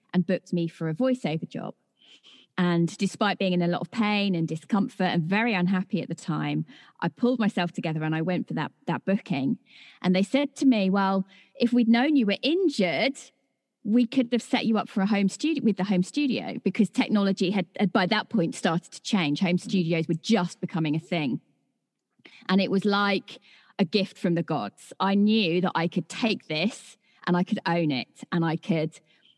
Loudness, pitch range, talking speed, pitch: -26 LUFS, 175-225 Hz, 205 wpm, 195 Hz